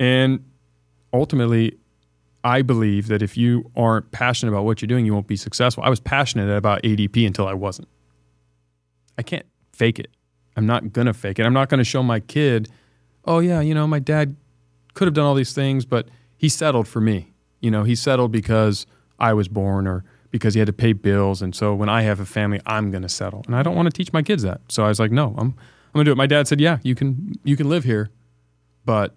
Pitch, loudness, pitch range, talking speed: 110 Hz, -20 LUFS, 100-130 Hz, 240 wpm